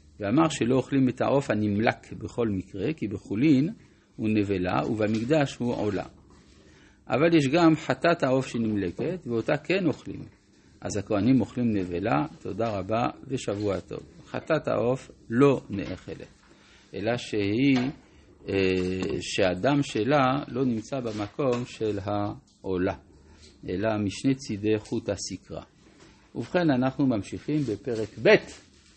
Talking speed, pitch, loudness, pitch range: 115 wpm, 110 Hz, -26 LUFS, 100-135 Hz